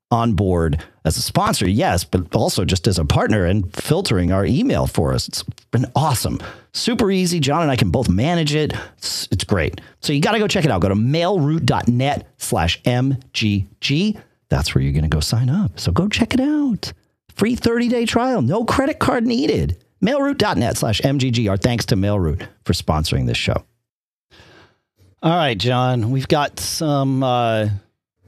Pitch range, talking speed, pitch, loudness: 105-165 Hz, 175 wpm, 125 Hz, -19 LUFS